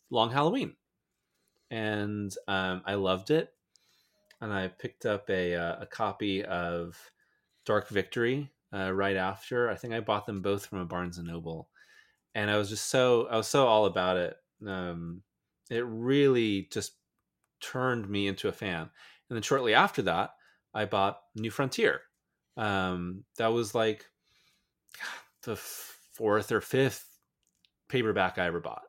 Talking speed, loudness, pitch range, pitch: 150 wpm, -30 LUFS, 95-115 Hz, 100 Hz